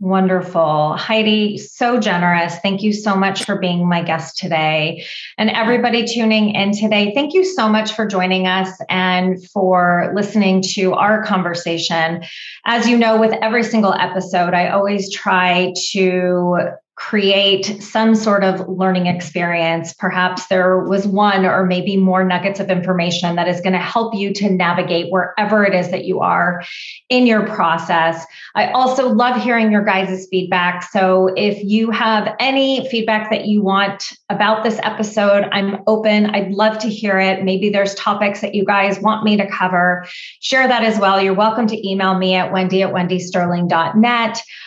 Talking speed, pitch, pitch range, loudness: 165 wpm, 195 Hz, 180-215 Hz, -16 LUFS